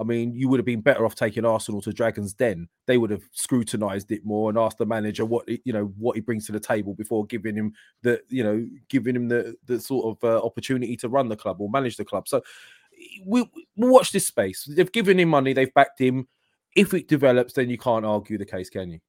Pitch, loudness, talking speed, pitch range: 120 Hz, -24 LUFS, 250 wpm, 110-135 Hz